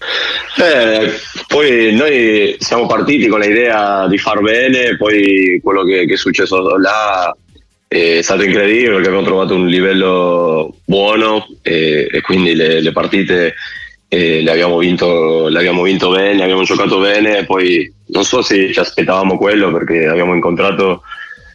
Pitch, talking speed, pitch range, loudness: 95 Hz, 150 wpm, 85-110 Hz, -11 LUFS